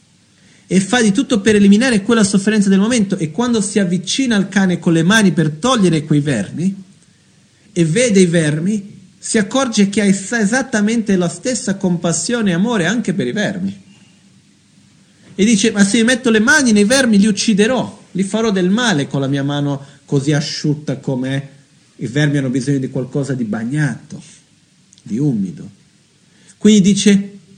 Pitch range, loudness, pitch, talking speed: 165-220 Hz, -15 LUFS, 195 Hz, 170 wpm